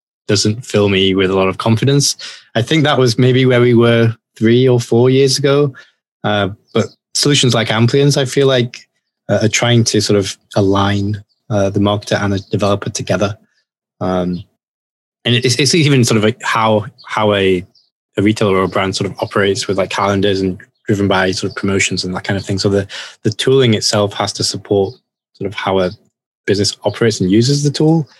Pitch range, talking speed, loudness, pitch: 100-125 Hz, 200 wpm, -14 LUFS, 105 Hz